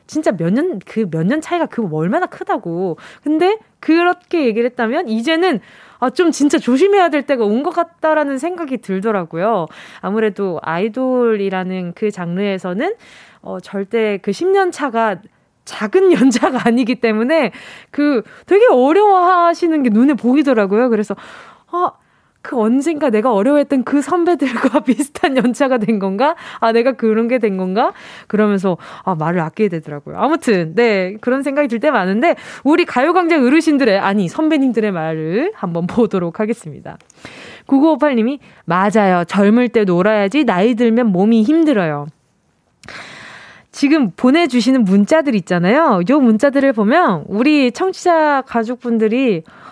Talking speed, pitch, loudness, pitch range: 315 characters per minute, 240 Hz, -15 LUFS, 205-300 Hz